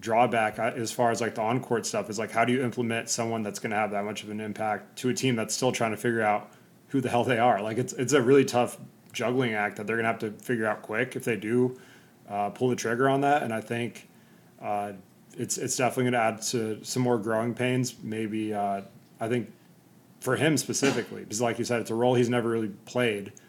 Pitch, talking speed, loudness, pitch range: 115 Hz, 250 wpm, -27 LUFS, 110-125 Hz